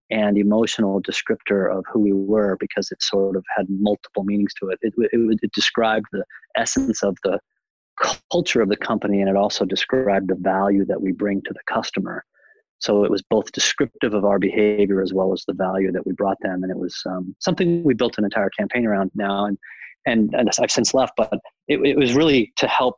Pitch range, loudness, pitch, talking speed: 95-105 Hz, -21 LUFS, 100 Hz, 220 wpm